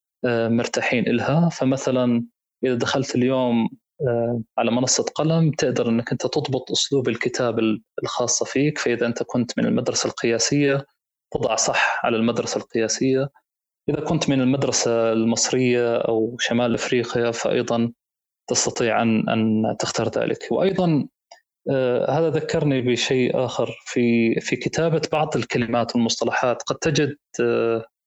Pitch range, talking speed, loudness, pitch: 115-140 Hz, 120 wpm, -21 LUFS, 125 Hz